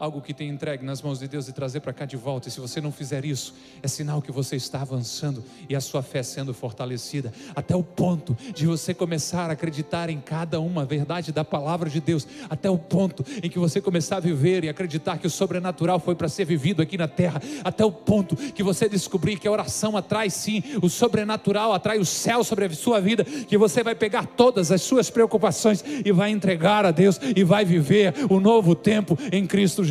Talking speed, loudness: 225 wpm, -24 LUFS